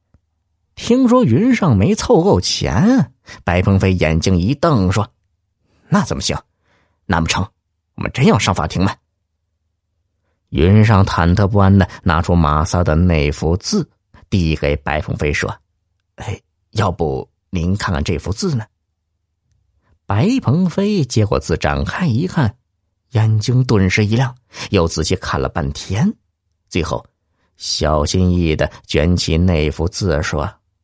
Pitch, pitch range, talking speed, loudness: 90 Hz, 85-105 Hz, 190 characters per minute, -16 LUFS